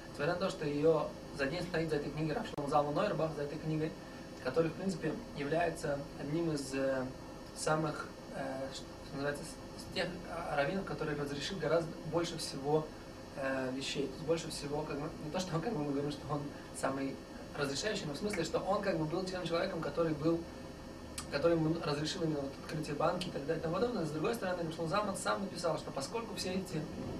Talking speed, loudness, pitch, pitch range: 200 wpm, -37 LUFS, 155 Hz, 145-170 Hz